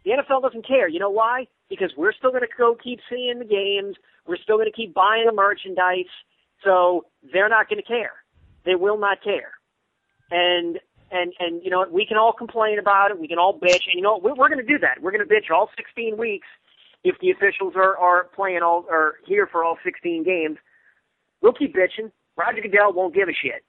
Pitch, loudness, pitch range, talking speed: 200 Hz, -21 LUFS, 180-245 Hz, 220 wpm